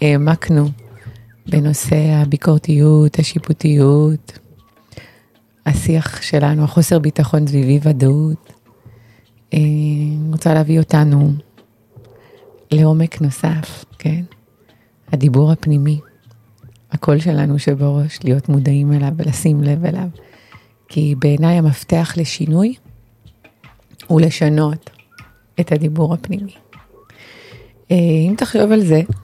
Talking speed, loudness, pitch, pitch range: 90 wpm, -15 LUFS, 150 Hz, 135-160 Hz